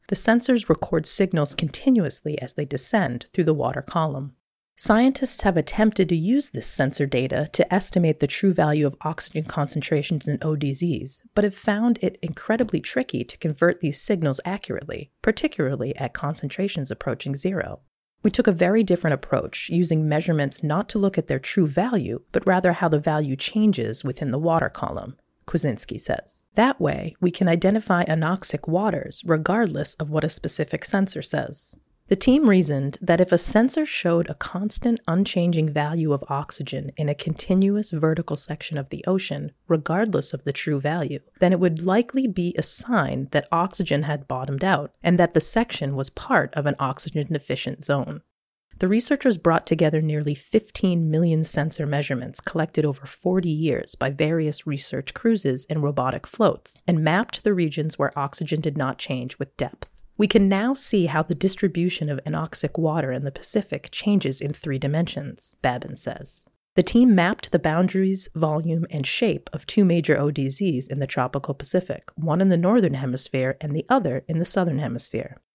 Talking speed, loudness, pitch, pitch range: 170 wpm, -22 LUFS, 160 Hz, 145-190 Hz